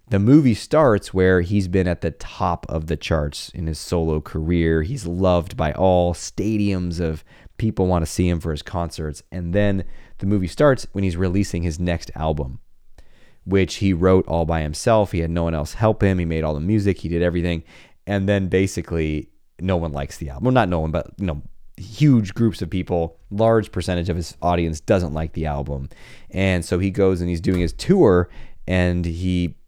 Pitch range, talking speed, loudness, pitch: 80-95 Hz, 205 wpm, -21 LUFS, 90 Hz